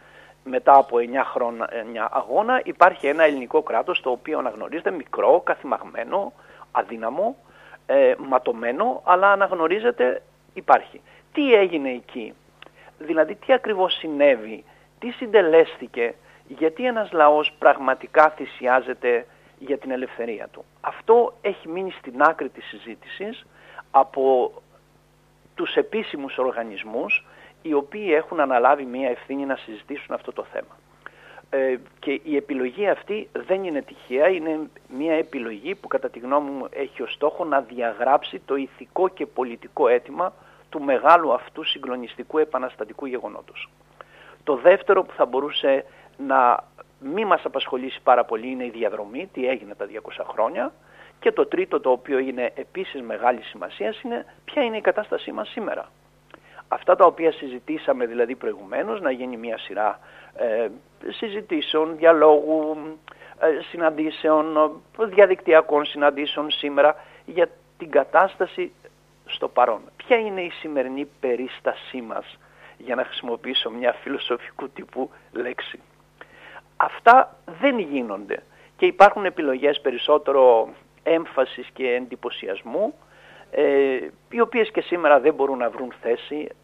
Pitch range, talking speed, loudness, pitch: 135-205 Hz, 125 wpm, -22 LUFS, 155 Hz